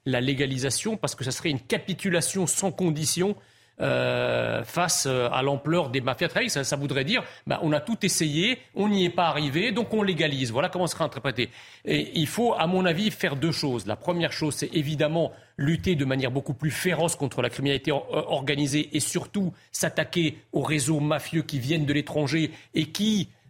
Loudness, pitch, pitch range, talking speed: -26 LUFS, 155 Hz, 140-175 Hz, 185 wpm